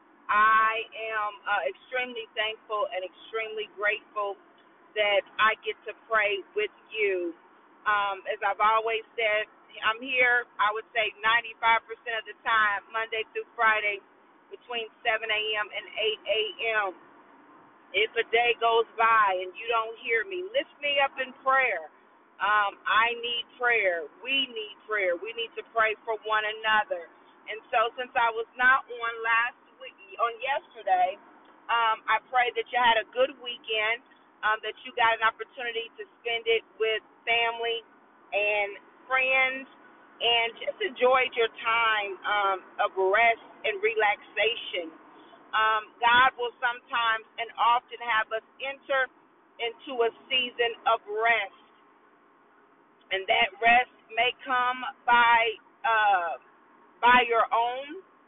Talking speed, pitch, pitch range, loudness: 135 wpm, 230 Hz, 220-260 Hz, -26 LUFS